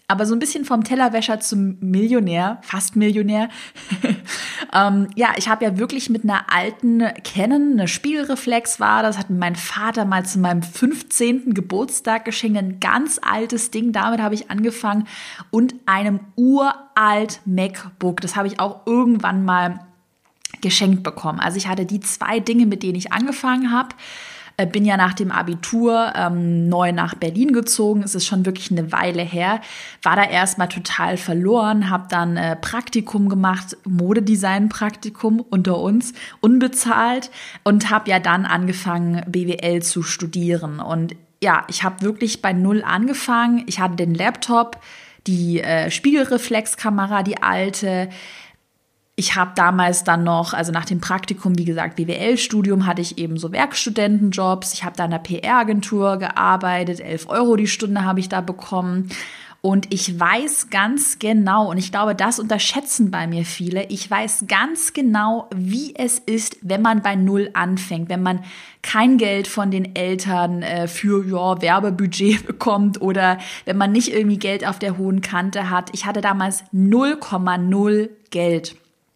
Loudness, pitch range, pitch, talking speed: -19 LUFS, 185-225 Hz, 200 Hz, 155 wpm